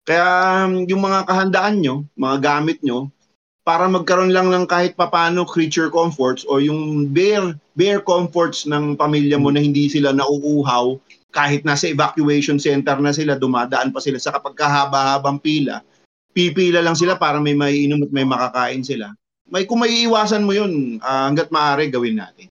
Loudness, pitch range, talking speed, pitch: -17 LUFS, 140-175 Hz, 165 wpm, 150 Hz